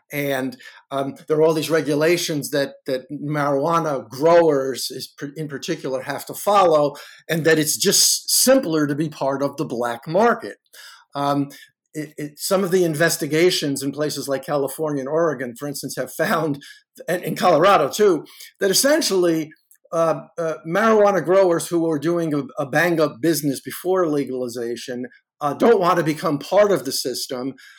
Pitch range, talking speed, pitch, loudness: 140-170 Hz, 160 wpm, 155 Hz, -20 LUFS